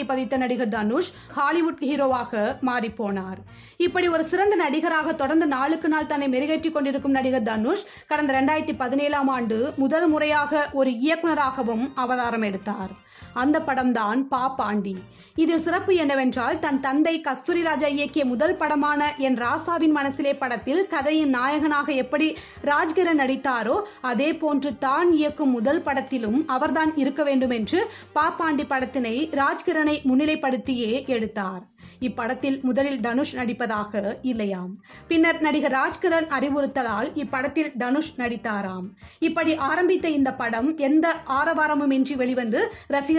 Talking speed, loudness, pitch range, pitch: 120 wpm, -23 LUFS, 255-310 Hz, 280 Hz